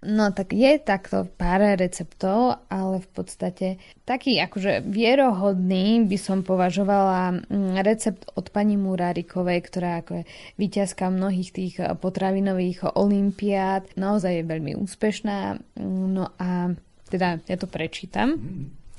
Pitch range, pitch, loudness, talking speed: 180-205 Hz, 190 Hz, -24 LUFS, 115 wpm